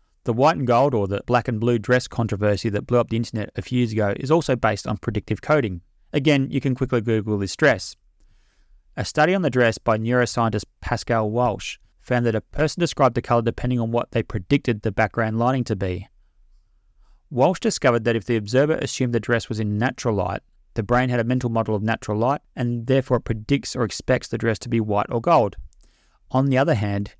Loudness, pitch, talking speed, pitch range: -22 LUFS, 120 Hz, 215 wpm, 110-130 Hz